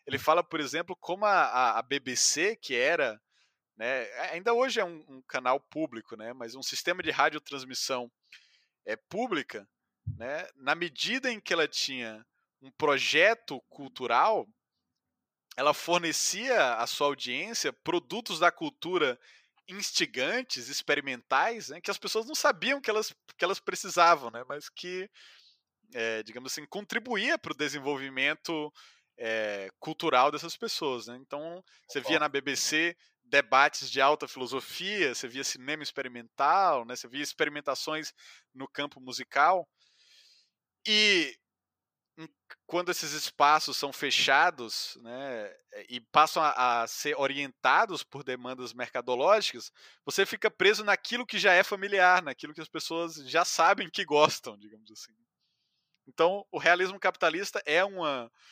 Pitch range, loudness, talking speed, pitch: 135-195 Hz, -28 LUFS, 135 wpm, 155 Hz